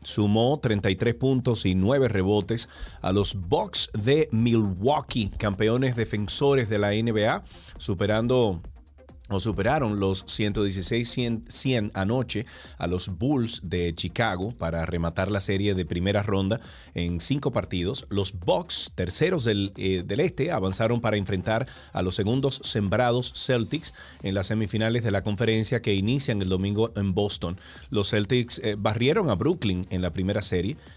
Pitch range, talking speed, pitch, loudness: 95-115 Hz, 145 wpm, 105 Hz, -25 LUFS